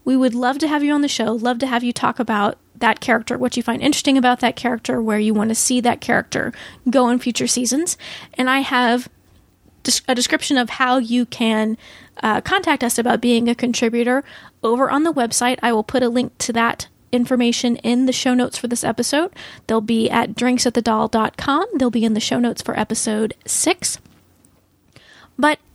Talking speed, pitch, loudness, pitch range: 195 wpm, 245 Hz, -18 LUFS, 230-255 Hz